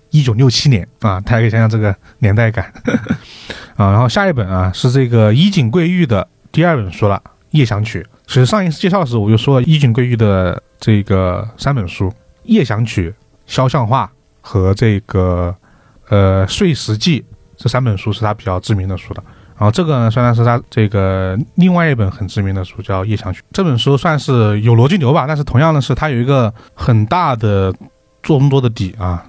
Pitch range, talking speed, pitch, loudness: 100-135 Hz, 290 characters per minute, 115 Hz, -14 LUFS